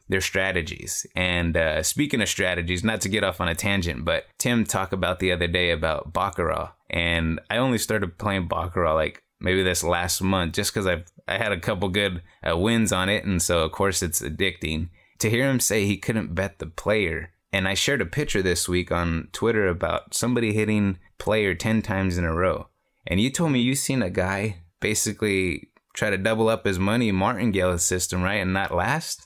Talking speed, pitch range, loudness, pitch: 205 wpm, 90-110 Hz, -24 LUFS, 95 Hz